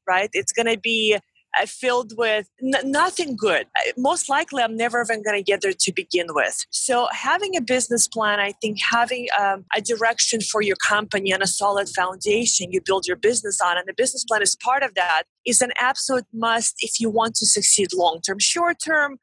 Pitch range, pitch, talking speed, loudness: 200-250 Hz, 225 Hz, 200 wpm, -20 LUFS